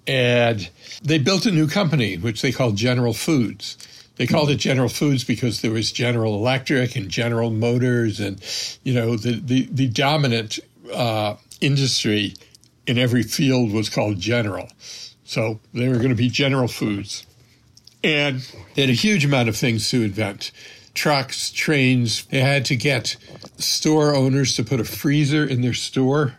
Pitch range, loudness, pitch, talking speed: 115-135 Hz, -20 LUFS, 125 Hz, 165 wpm